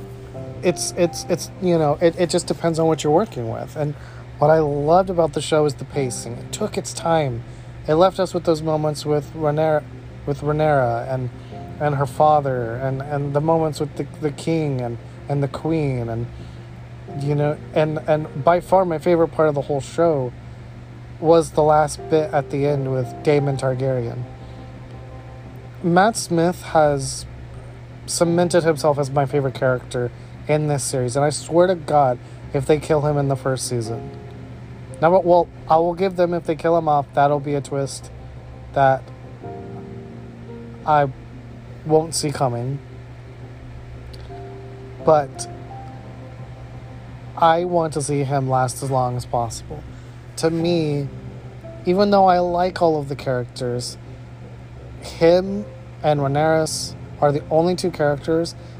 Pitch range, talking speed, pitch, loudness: 125-155 Hz, 155 wpm, 140 Hz, -20 LUFS